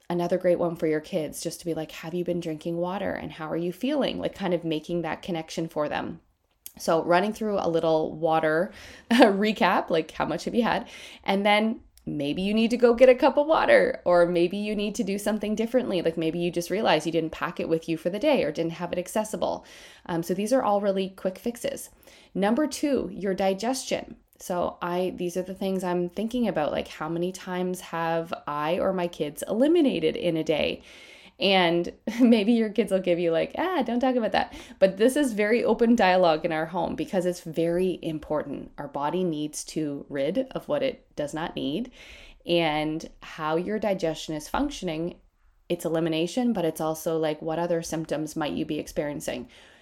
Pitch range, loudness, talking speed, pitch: 165-215 Hz, -26 LUFS, 205 wpm, 180 Hz